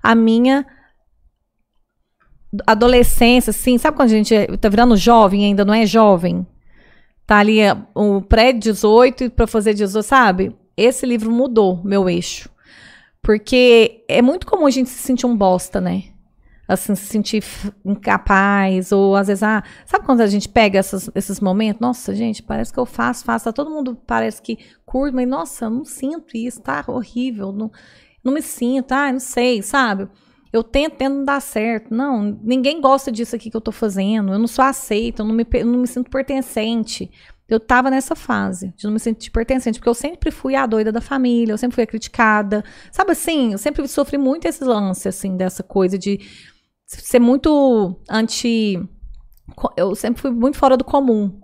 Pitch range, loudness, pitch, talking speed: 205-255 Hz, -17 LUFS, 230 Hz, 180 wpm